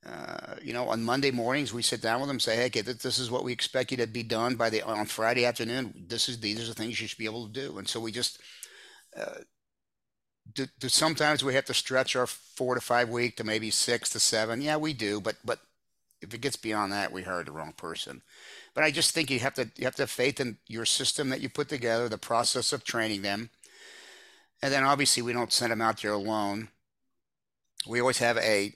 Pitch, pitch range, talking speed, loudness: 120 Hz, 110-130 Hz, 240 wpm, -28 LUFS